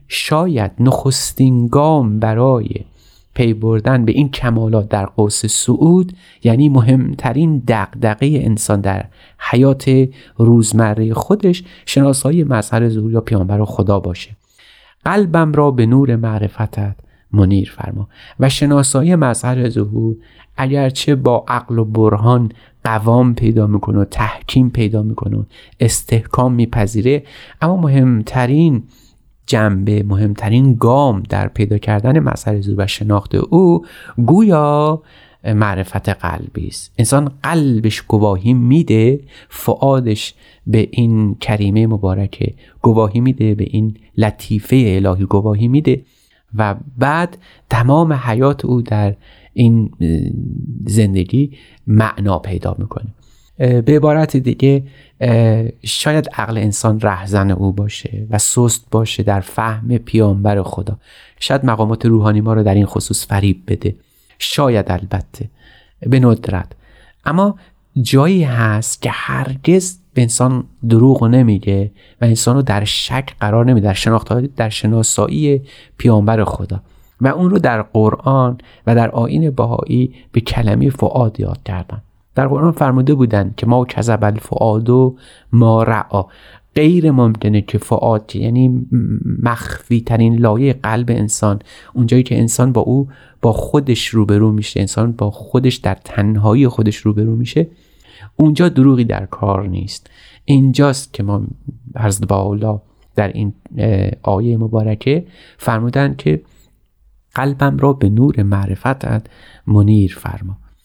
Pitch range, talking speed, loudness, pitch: 105-130 Hz, 120 wpm, -14 LUFS, 115 Hz